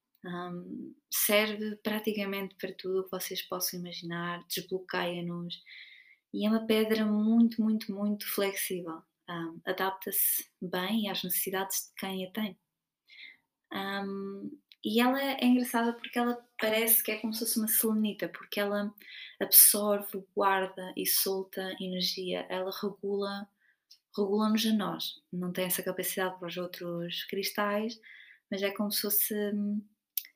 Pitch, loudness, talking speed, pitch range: 200 Hz, -30 LUFS, 135 wpm, 185-215 Hz